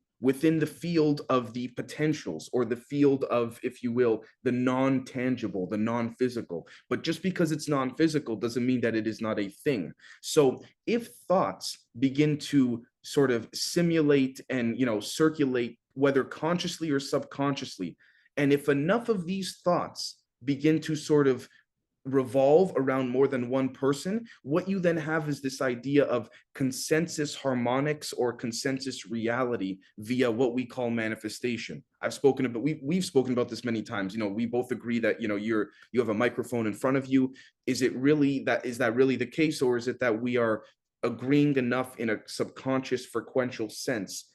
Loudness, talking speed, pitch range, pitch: -28 LUFS, 175 wpm, 120-145 Hz, 130 Hz